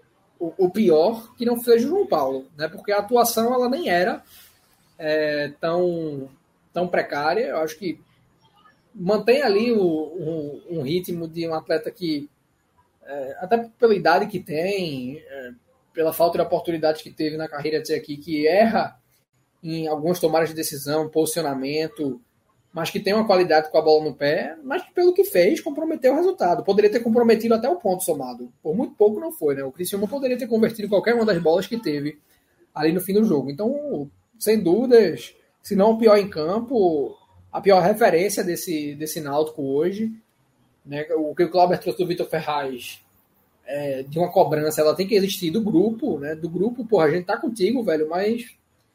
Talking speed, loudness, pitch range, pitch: 185 wpm, -22 LUFS, 155-220 Hz, 175 Hz